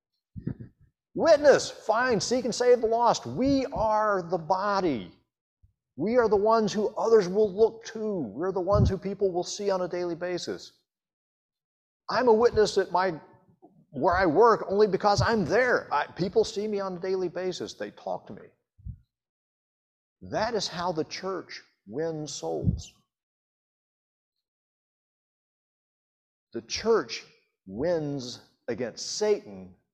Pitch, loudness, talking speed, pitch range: 195 Hz, -26 LUFS, 135 wpm, 180-220 Hz